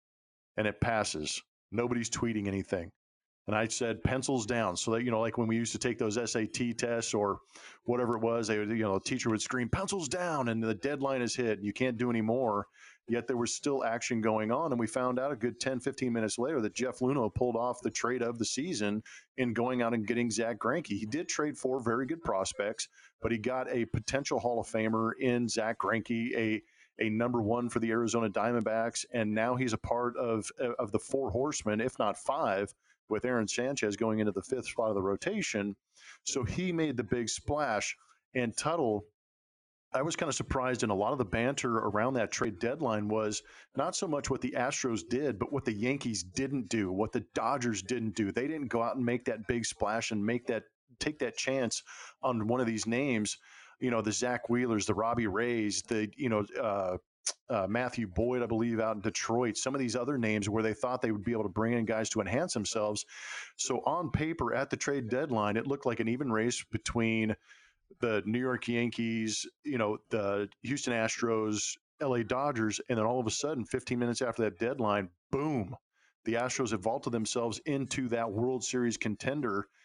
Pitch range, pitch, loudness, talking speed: 110-125 Hz, 115 Hz, -33 LUFS, 210 wpm